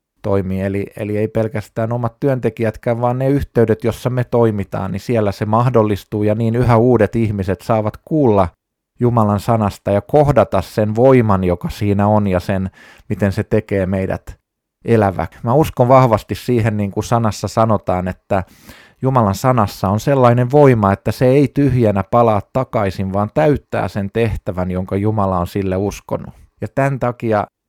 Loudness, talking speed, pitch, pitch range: -16 LUFS, 155 wpm, 110 Hz, 100-120 Hz